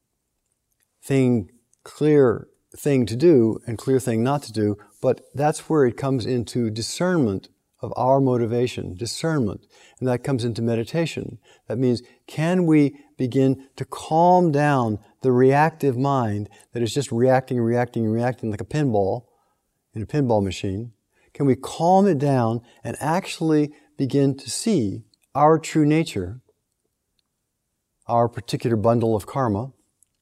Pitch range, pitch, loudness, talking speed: 115-145 Hz, 125 Hz, -22 LUFS, 135 wpm